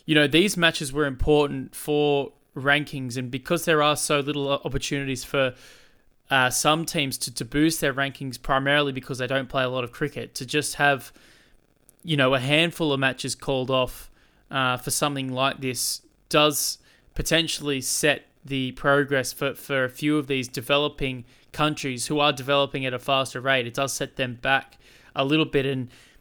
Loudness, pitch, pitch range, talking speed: -24 LUFS, 140 Hz, 130-150 Hz, 180 wpm